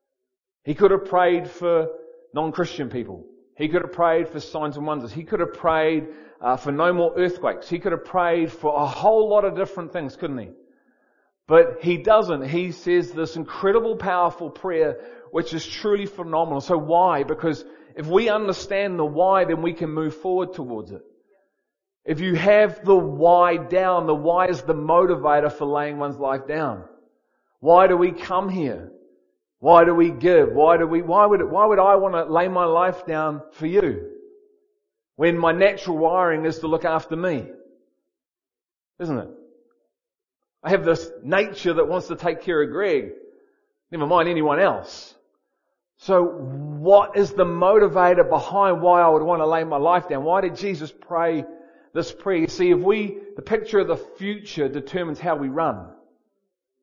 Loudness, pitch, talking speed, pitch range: -20 LUFS, 175 Hz, 175 wpm, 160-195 Hz